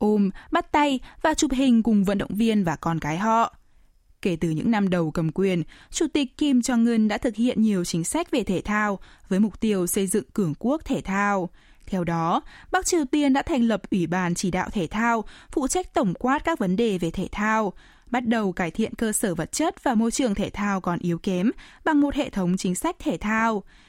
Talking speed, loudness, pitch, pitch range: 230 wpm, -24 LUFS, 215 Hz, 190-265 Hz